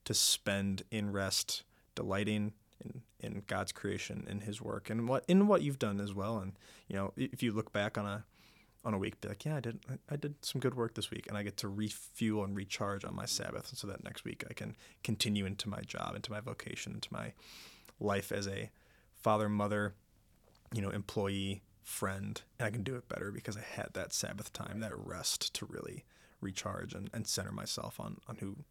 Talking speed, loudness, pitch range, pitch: 215 wpm, -38 LUFS, 100-115 Hz, 105 Hz